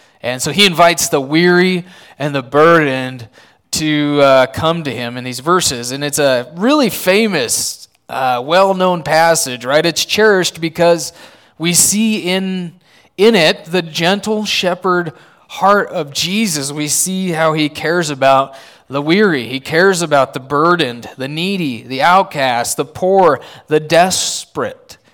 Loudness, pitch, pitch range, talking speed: -13 LUFS, 165 Hz, 140-185 Hz, 150 wpm